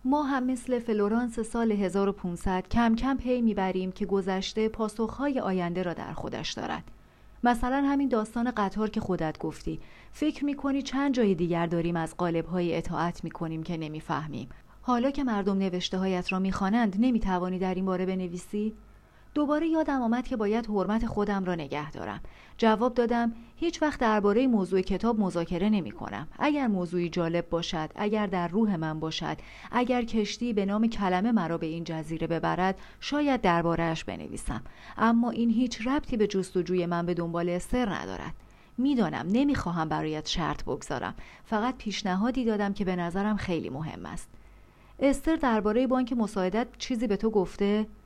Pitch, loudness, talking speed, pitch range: 205 Hz, -29 LUFS, 155 wpm, 180-240 Hz